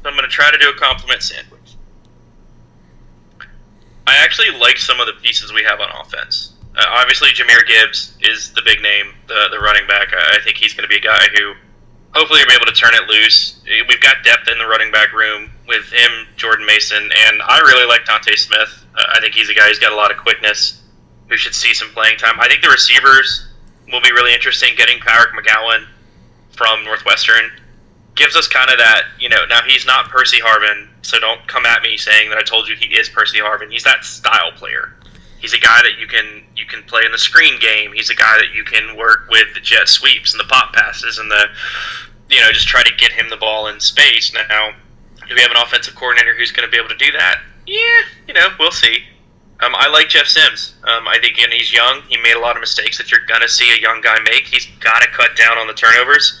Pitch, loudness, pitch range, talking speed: 110 Hz, -10 LUFS, 105-125 Hz, 240 wpm